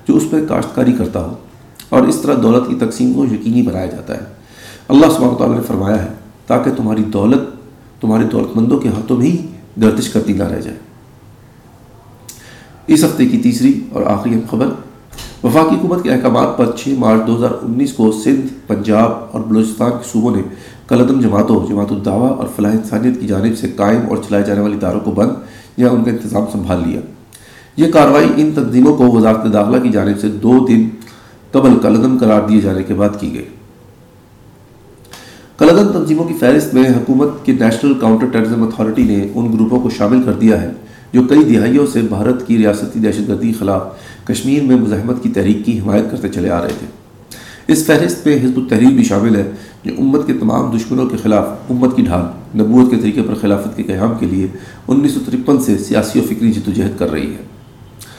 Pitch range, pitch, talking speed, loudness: 105-130 Hz, 115 Hz, 190 wpm, -13 LUFS